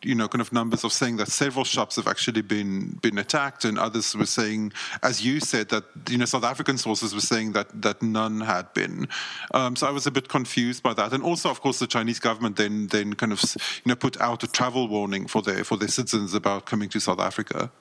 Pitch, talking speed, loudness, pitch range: 115 Hz, 245 wpm, -25 LUFS, 105-125 Hz